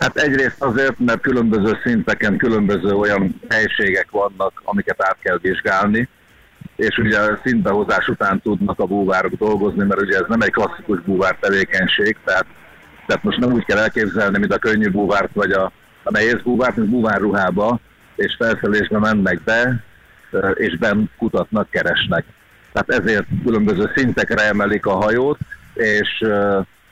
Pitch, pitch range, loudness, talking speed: 105 Hz, 100-115 Hz, -17 LUFS, 140 wpm